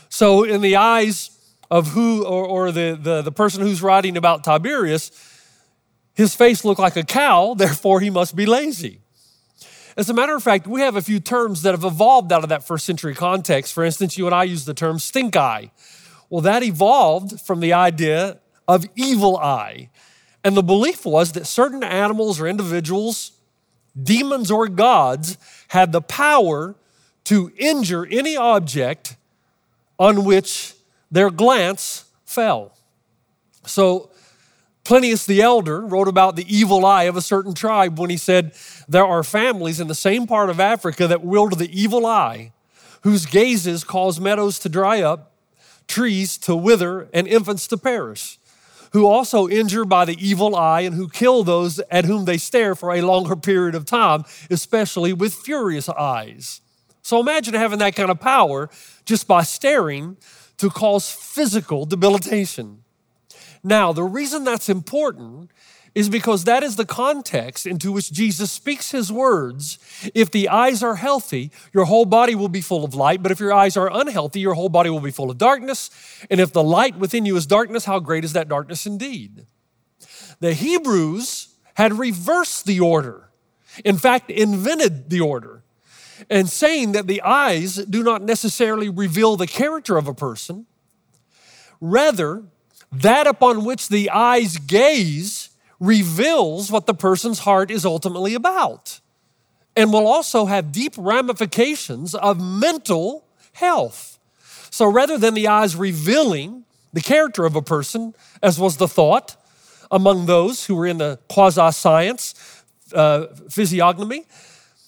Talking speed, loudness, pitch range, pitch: 160 wpm, -18 LUFS, 170-225 Hz, 195 Hz